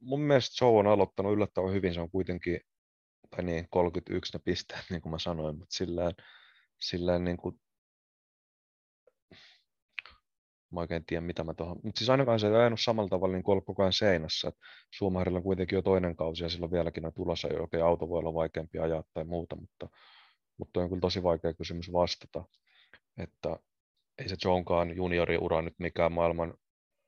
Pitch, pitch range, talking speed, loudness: 90 Hz, 85-95 Hz, 180 wpm, -31 LUFS